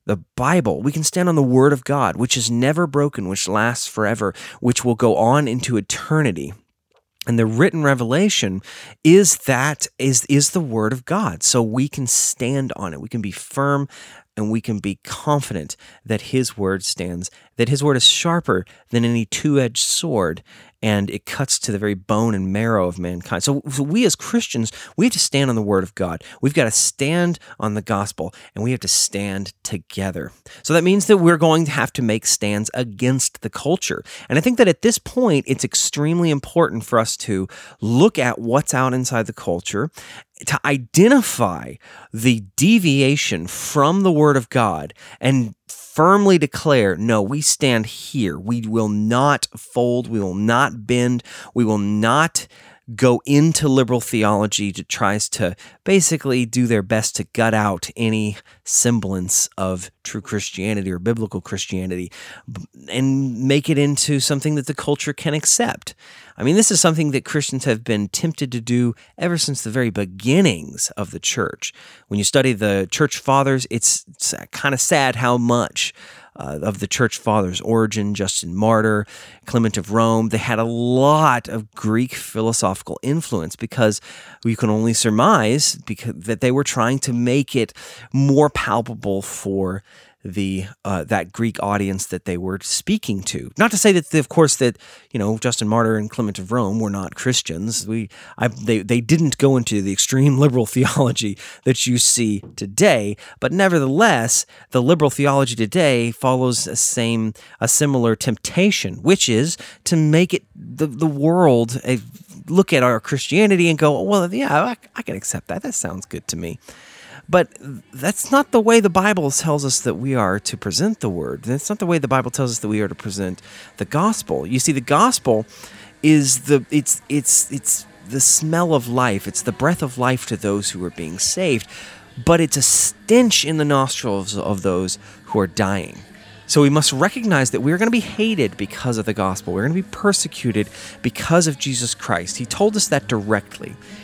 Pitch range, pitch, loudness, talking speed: 105-145 Hz, 125 Hz, -18 LUFS, 185 wpm